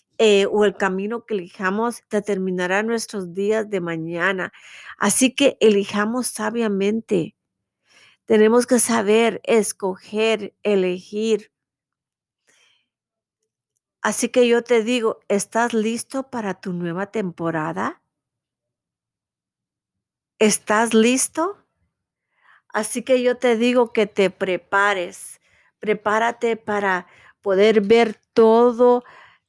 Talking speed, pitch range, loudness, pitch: 95 wpm, 195-235 Hz, -20 LUFS, 215 Hz